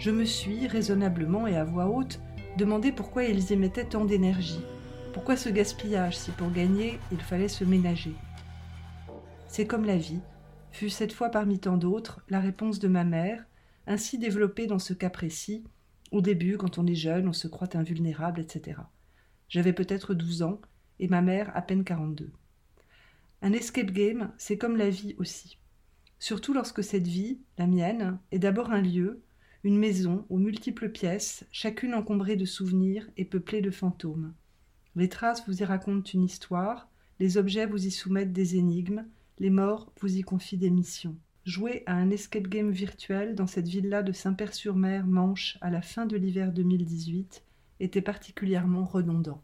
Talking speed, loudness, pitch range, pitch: 170 wpm, -29 LUFS, 180-210 Hz, 190 Hz